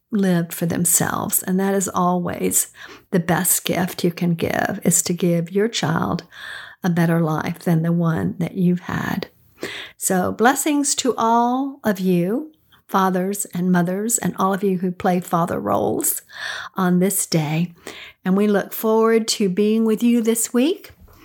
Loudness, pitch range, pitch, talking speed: -20 LUFS, 175-220 Hz, 190 Hz, 160 wpm